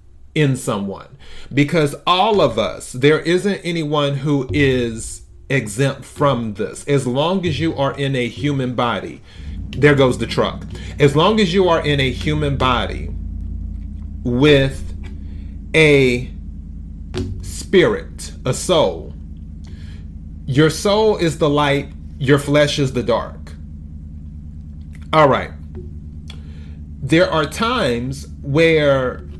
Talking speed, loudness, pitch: 115 wpm, -17 LUFS, 115 Hz